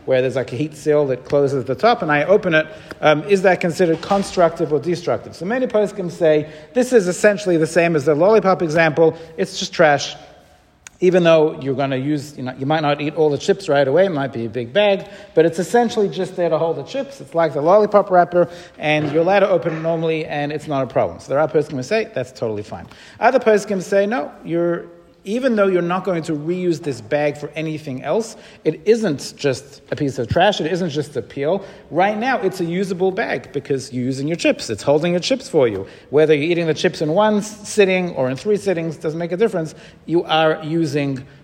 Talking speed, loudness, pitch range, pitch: 235 wpm, -18 LUFS, 150-190 Hz, 165 Hz